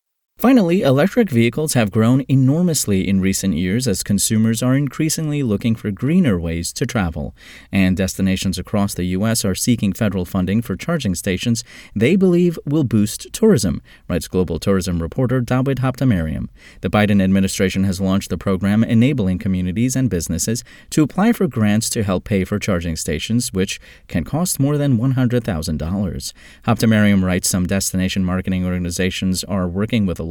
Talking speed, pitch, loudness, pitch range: 155 wpm, 100 Hz, -18 LUFS, 95-125 Hz